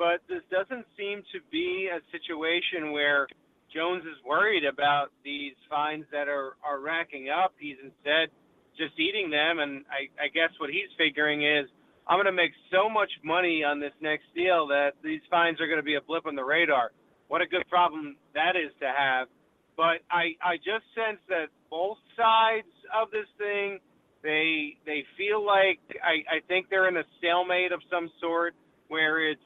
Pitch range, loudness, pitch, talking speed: 150-185 Hz, -27 LUFS, 165 Hz, 180 wpm